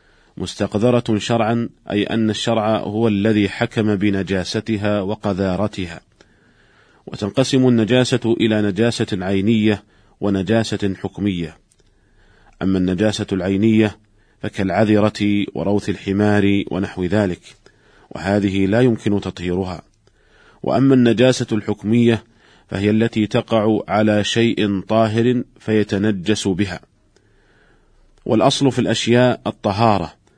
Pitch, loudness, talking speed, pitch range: 105 Hz, -18 LUFS, 85 wpm, 100-115 Hz